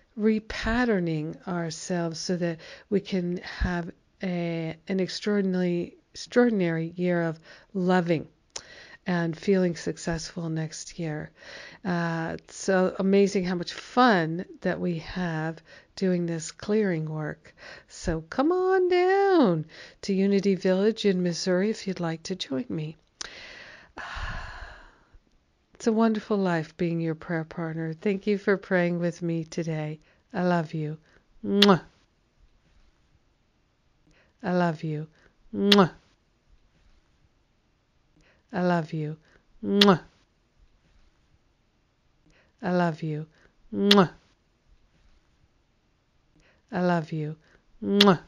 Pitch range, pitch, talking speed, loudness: 165-200 Hz, 180 Hz, 100 wpm, -26 LUFS